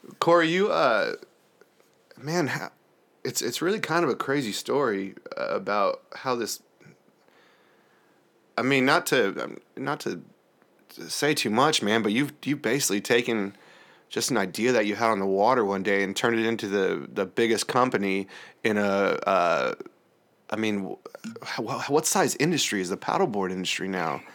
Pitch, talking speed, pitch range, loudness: 100 Hz, 155 wpm, 95-115 Hz, -25 LUFS